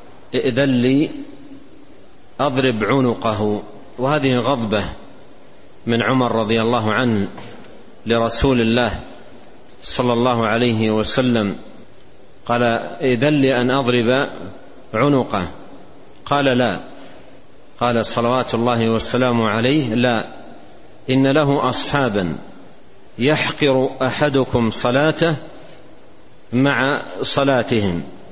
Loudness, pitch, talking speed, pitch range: -18 LUFS, 125 Hz, 85 wpm, 115-135 Hz